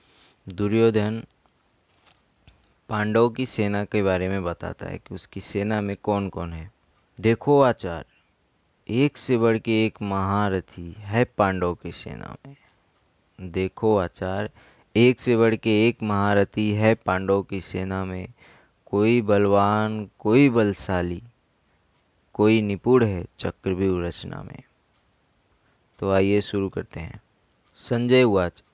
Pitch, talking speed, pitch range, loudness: 100 Hz, 125 wpm, 95-110 Hz, -23 LUFS